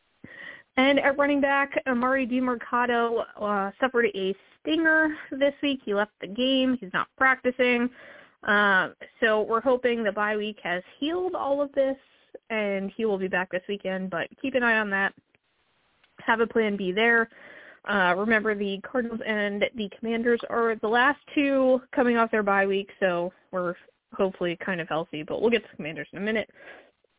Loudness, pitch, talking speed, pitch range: -25 LUFS, 230 Hz, 180 wpm, 200-265 Hz